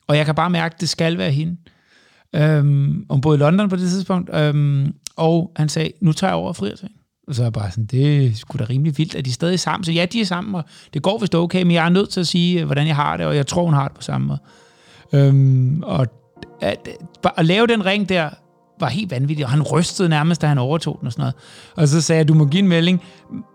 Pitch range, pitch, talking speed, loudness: 145-180 Hz, 160 Hz, 275 wpm, -18 LUFS